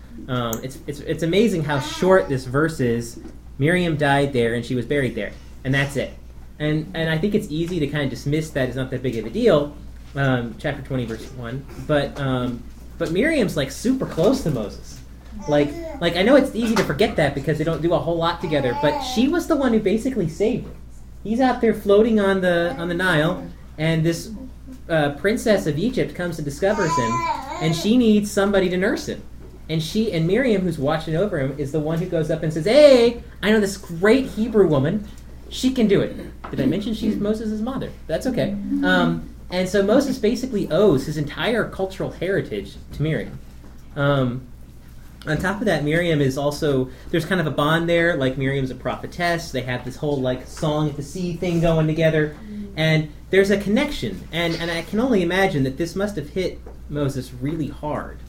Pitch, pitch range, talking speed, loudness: 160 Hz, 140-195 Hz, 205 wpm, -21 LUFS